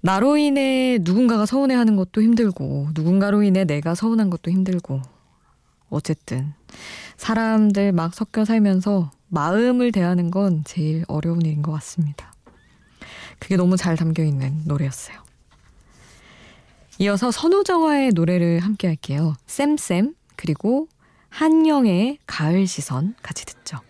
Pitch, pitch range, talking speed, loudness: 190 Hz, 160-225 Hz, 280 characters per minute, -20 LUFS